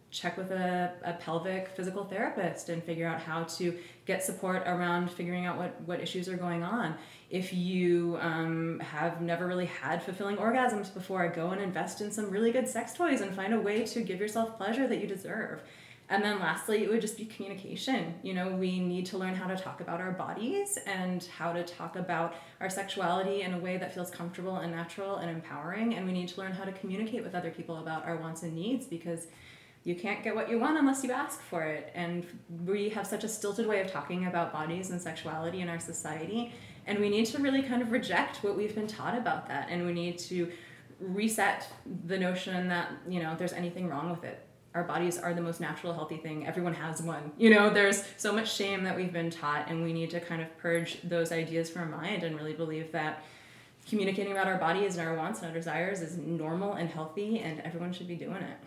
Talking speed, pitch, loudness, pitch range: 225 wpm, 180 Hz, -33 LUFS, 170-200 Hz